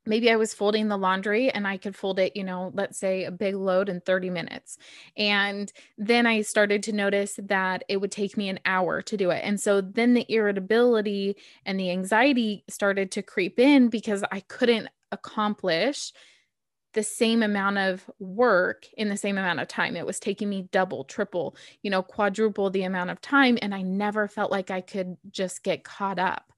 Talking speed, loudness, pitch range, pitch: 200 wpm, -25 LUFS, 190-220 Hz, 200 Hz